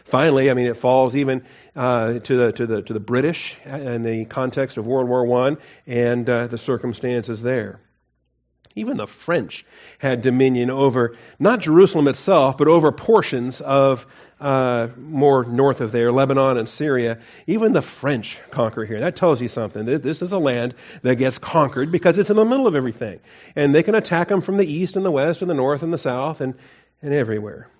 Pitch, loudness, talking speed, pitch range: 130 Hz, -19 LUFS, 195 wpm, 120-150 Hz